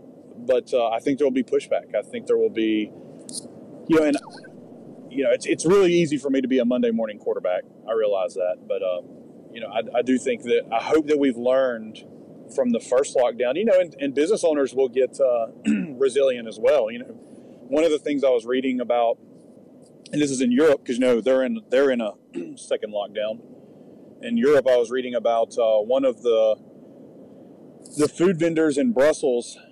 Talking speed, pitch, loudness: 210 wpm, 235 Hz, -22 LUFS